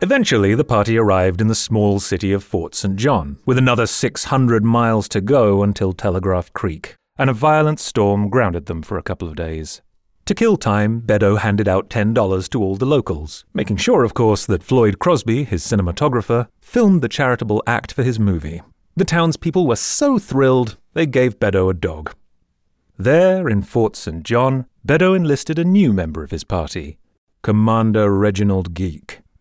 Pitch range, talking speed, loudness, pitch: 95-130 Hz, 175 wpm, -17 LUFS, 105 Hz